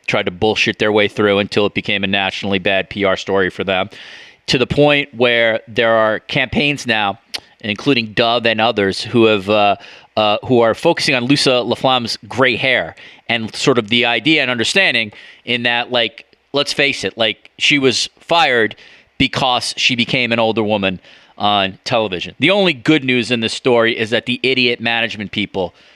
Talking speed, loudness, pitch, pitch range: 180 wpm, -15 LUFS, 115 Hz, 105-125 Hz